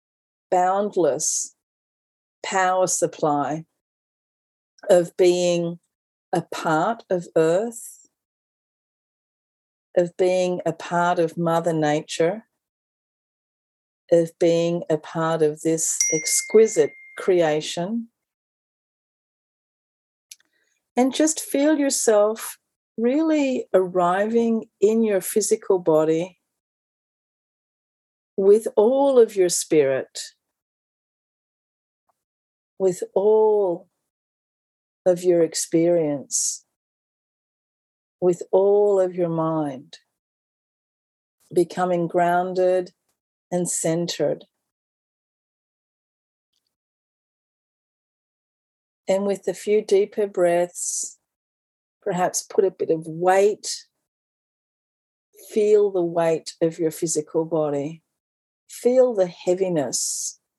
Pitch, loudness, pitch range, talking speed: 180 Hz, -21 LUFS, 165-215 Hz, 75 wpm